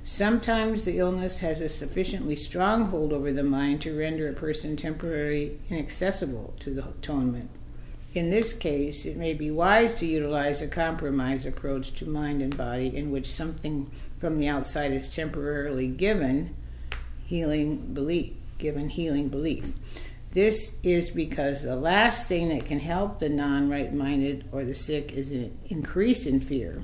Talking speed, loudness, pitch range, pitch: 155 wpm, -28 LUFS, 140-165 Hz, 150 Hz